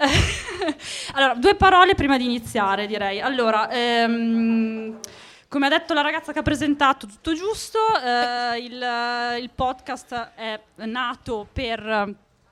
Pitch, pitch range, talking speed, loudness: 245 Hz, 225-285 Hz, 125 wpm, -22 LUFS